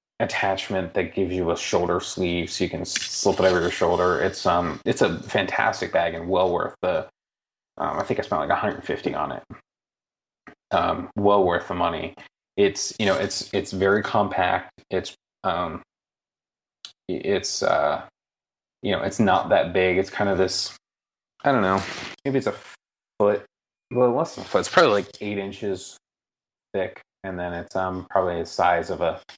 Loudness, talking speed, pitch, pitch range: -24 LUFS, 180 wpm, 95 Hz, 95-100 Hz